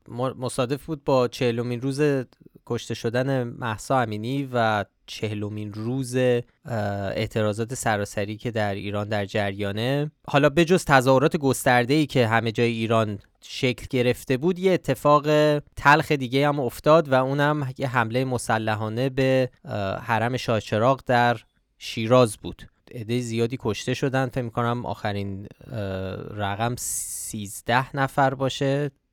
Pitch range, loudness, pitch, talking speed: 110-135 Hz, -24 LUFS, 125 Hz, 120 wpm